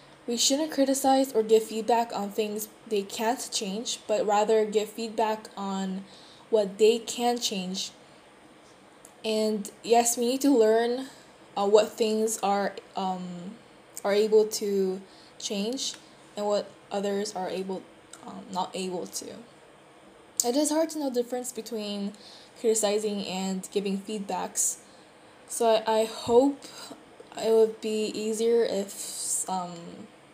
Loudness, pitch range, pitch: -27 LUFS, 200-235 Hz, 220 Hz